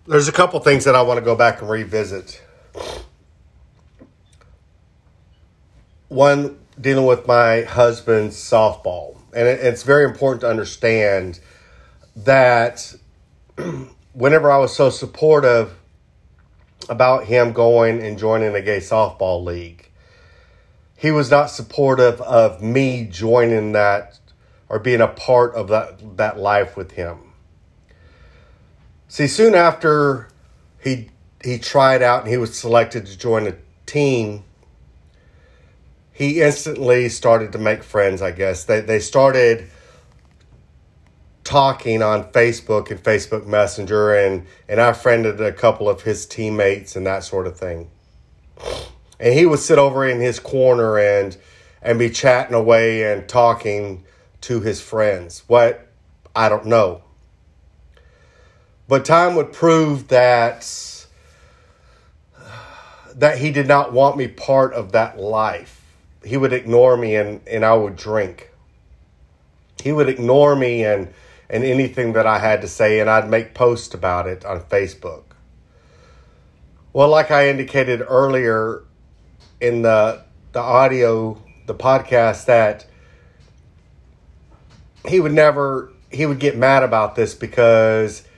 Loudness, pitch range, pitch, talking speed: -16 LUFS, 95-125 Hz, 110 Hz, 130 wpm